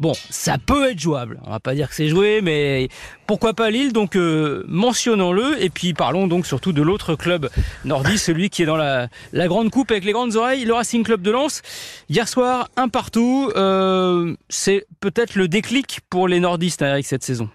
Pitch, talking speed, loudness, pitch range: 190 Hz, 205 wpm, -19 LUFS, 160-225 Hz